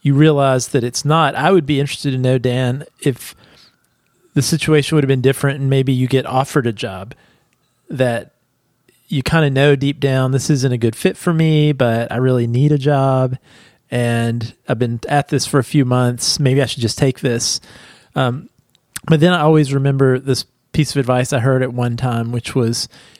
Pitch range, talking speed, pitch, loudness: 125-145 Hz, 200 wpm, 135 Hz, -16 LUFS